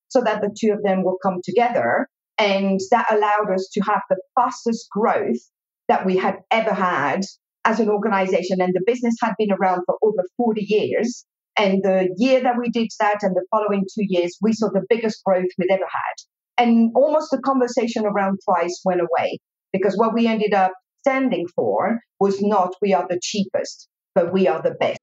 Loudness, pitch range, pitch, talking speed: -20 LUFS, 190-230 Hz, 205 Hz, 195 wpm